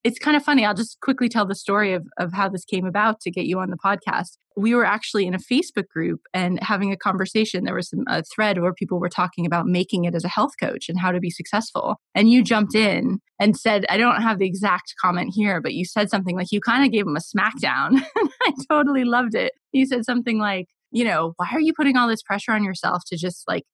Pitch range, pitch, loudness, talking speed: 185-235 Hz, 210 Hz, -21 LUFS, 255 wpm